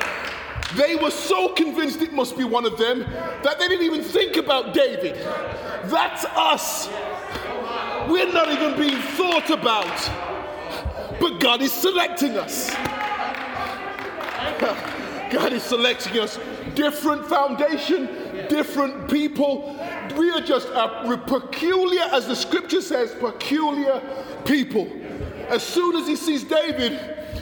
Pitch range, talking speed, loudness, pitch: 265-330 Hz, 120 wpm, -22 LUFS, 300 Hz